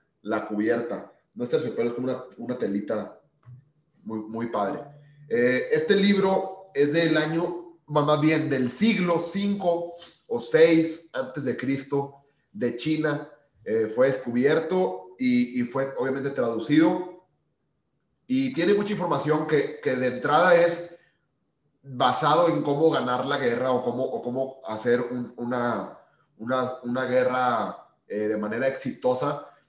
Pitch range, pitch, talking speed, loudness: 125-165 Hz, 145 Hz, 135 wpm, -25 LUFS